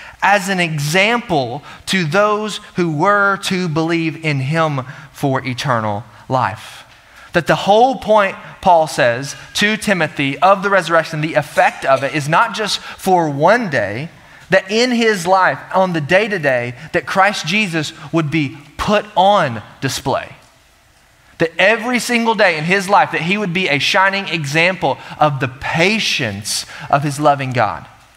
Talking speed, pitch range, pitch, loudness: 155 wpm, 145-195 Hz, 165 Hz, -15 LUFS